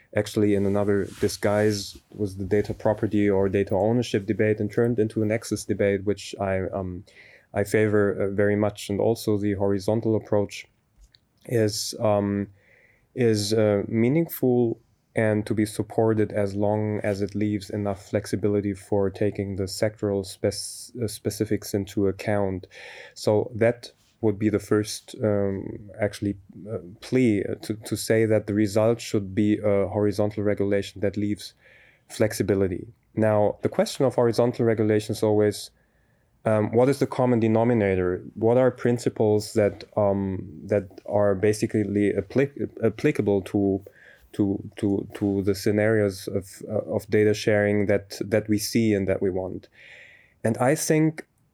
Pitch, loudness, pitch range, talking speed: 105 Hz, -24 LUFS, 100-110 Hz, 145 wpm